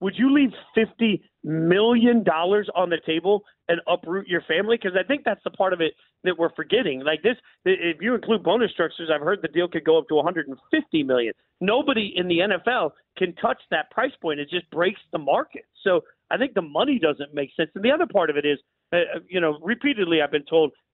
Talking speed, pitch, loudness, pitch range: 220 wpm, 180 Hz, -23 LUFS, 160-230 Hz